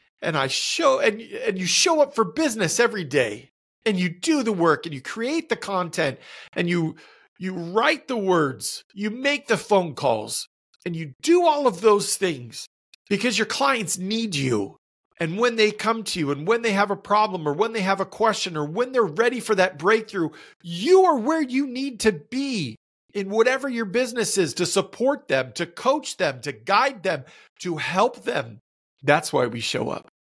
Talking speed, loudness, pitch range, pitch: 195 wpm, -23 LUFS, 175-245 Hz, 215 Hz